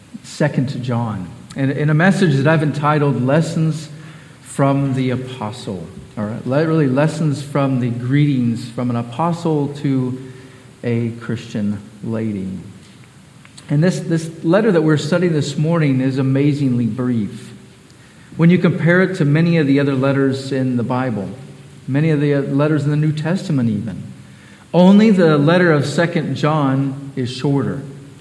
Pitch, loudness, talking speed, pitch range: 140 Hz, -17 LUFS, 150 wpm, 130-155 Hz